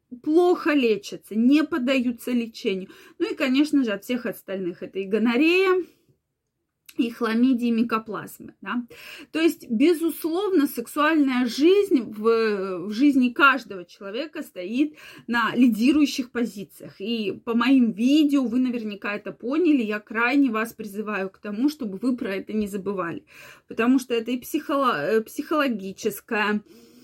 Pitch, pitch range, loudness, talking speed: 245 Hz, 215-290 Hz, -23 LUFS, 135 wpm